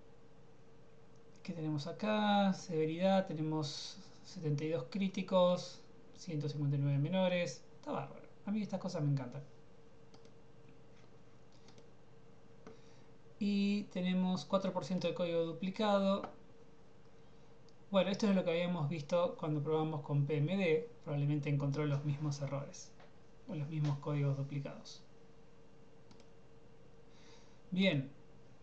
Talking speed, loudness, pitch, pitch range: 95 wpm, -36 LUFS, 155 Hz, 150-185 Hz